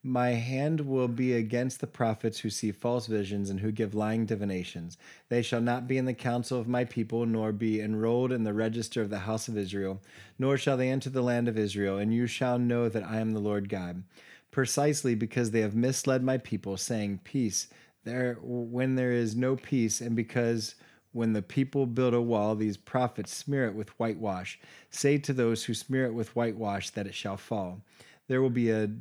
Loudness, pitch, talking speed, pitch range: -30 LUFS, 115 Hz, 205 wpm, 110-125 Hz